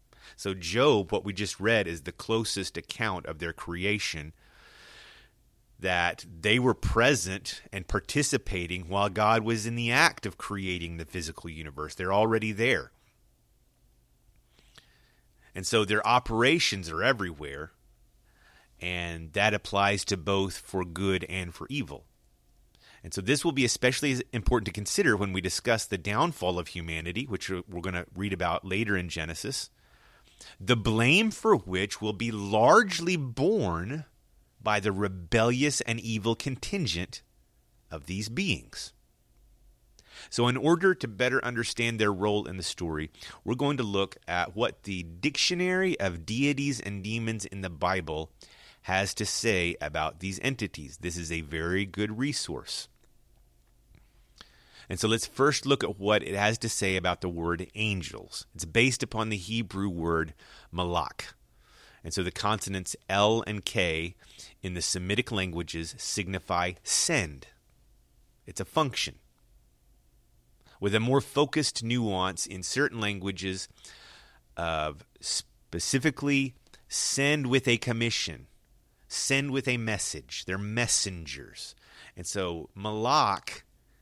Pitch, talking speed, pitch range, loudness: 100 Hz, 135 wpm, 90-115 Hz, -28 LUFS